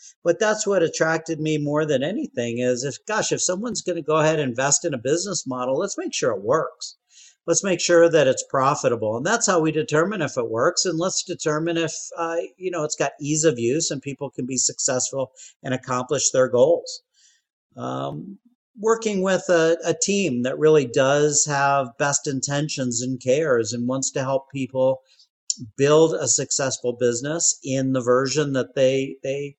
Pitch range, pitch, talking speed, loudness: 135-180 Hz, 155 Hz, 185 wpm, -22 LUFS